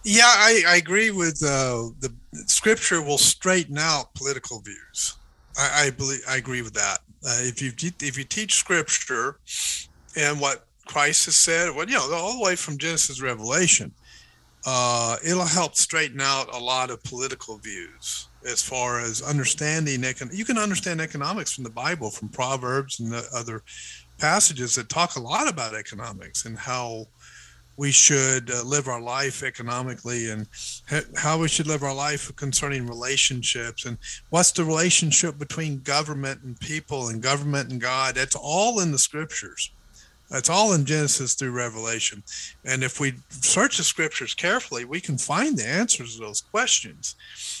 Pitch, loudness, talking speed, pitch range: 135 Hz, -22 LUFS, 165 wpm, 120-160 Hz